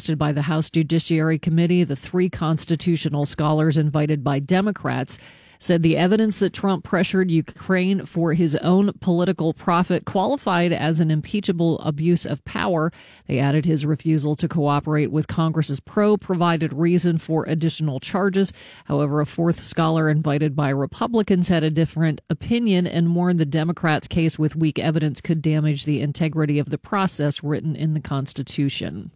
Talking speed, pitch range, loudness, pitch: 155 wpm, 150-175 Hz, -21 LUFS, 160 Hz